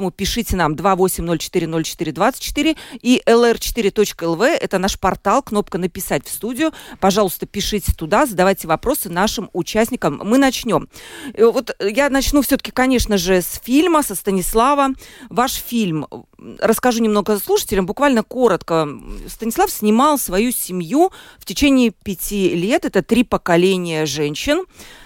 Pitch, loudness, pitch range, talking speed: 210 Hz, -17 LUFS, 185-255 Hz, 120 wpm